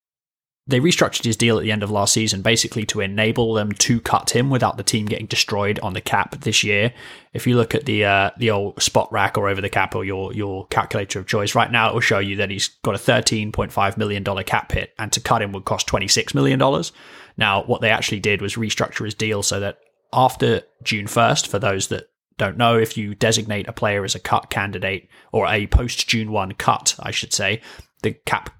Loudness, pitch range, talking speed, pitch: -20 LUFS, 100-115 Hz, 235 wpm, 105 Hz